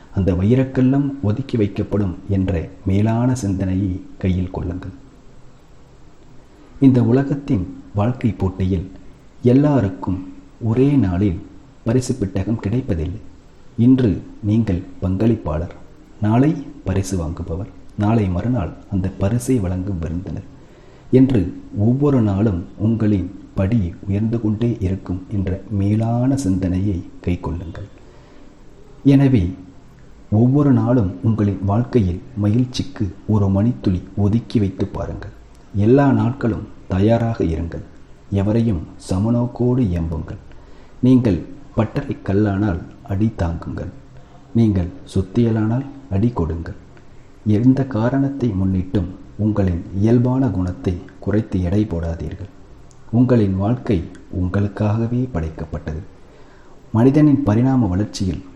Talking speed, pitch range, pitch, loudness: 90 wpm, 95-120 Hz, 105 Hz, -19 LUFS